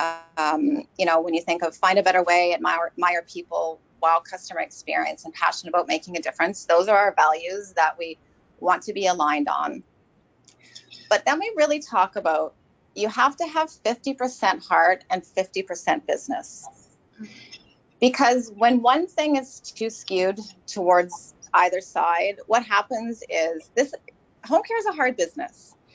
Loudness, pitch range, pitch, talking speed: -23 LUFS, 170-245 Hz, 185 Hz, 160 wpm